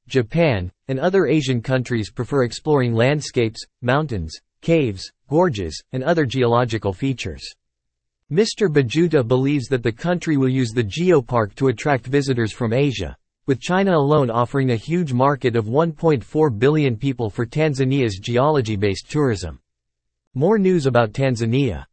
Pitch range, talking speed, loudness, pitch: 115-150 Hz, 135 wpm, -20 LUFS, 130 Hz